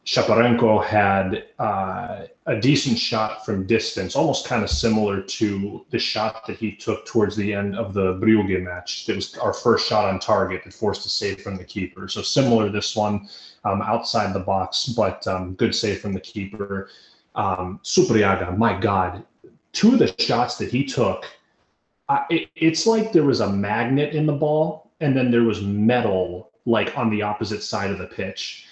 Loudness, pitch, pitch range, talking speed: -22 LUFS, 105 Hz, 95-115 Hz, 190 wpm